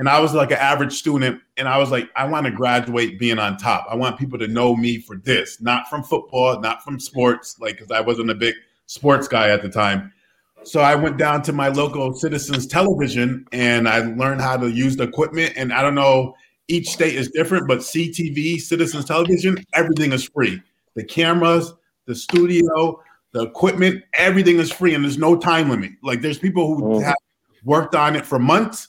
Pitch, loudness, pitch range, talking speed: 140 Hz, -19 LUFS, 125-165 Hz, 205 wpm